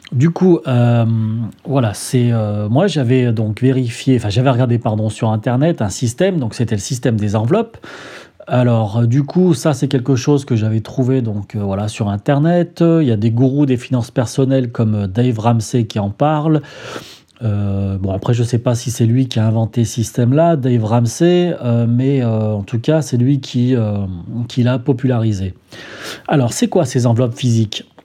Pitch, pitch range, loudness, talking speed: 120 Hz, 110-135 Hz, -16 LUFS, 195 wpm